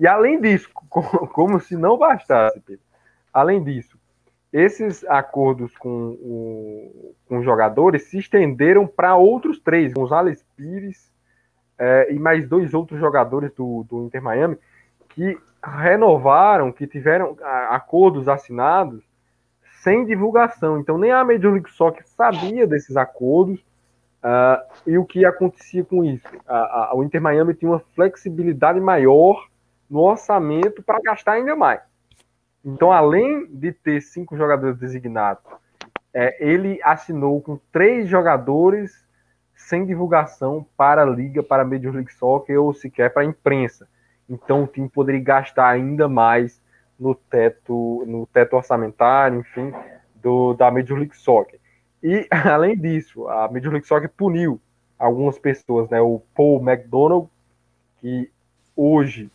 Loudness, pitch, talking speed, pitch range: -18 LUFS, 140 Hz, 135 wpm, 125-175 Hz